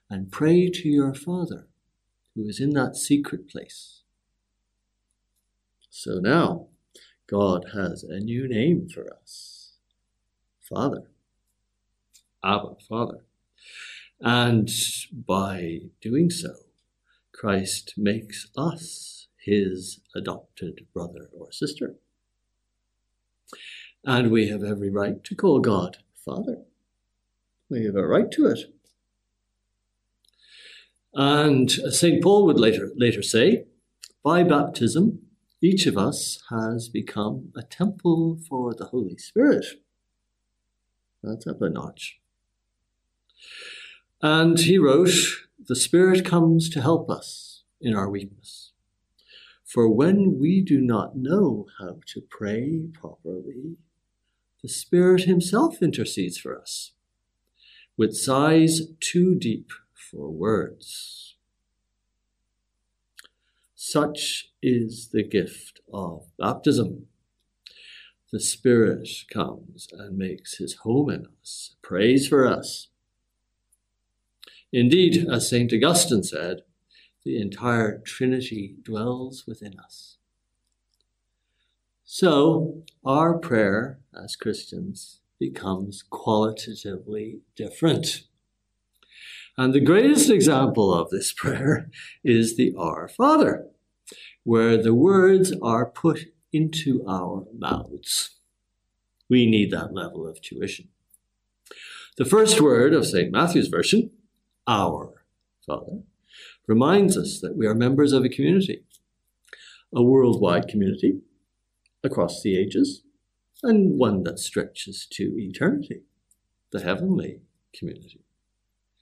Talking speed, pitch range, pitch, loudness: 100 wpm, 100-160 Hz, 115 Hz, -22 LUFS